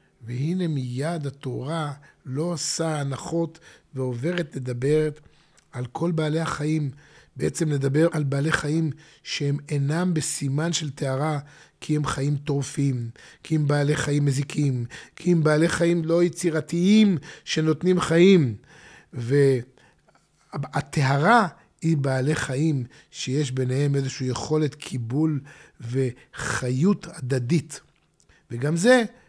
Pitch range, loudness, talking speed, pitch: 135-160 Hz, -24 LUFS, 105 wpm, 150 Hz